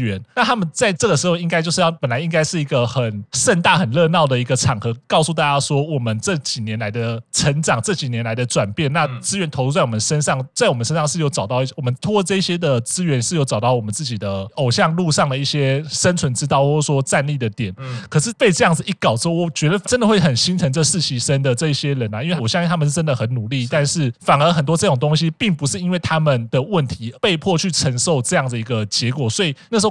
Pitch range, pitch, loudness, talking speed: 125-170 Hz, 145 Hz, -18 LUFS, 370 characters per minute